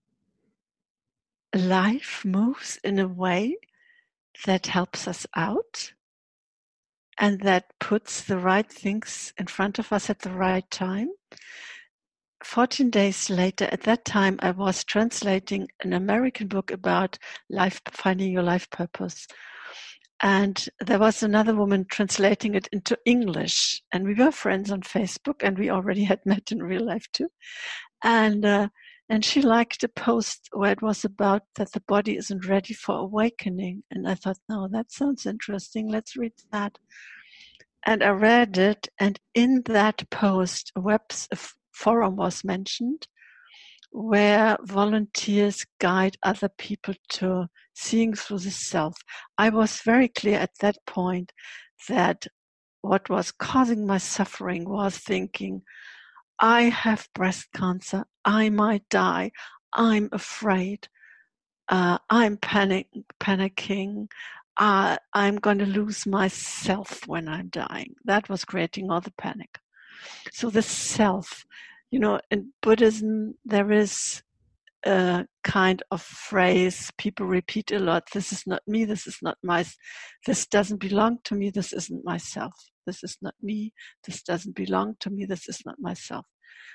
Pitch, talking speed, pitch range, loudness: 205 Hz, 145 wpm, 190-220 Hz, -25 LUFS